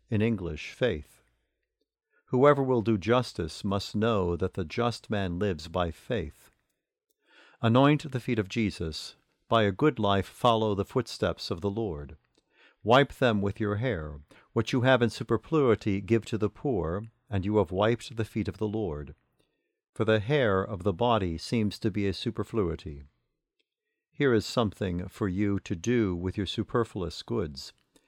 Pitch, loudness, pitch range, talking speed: 105 Hz, -28 LUFS, 95-120 Hz, 160 wpm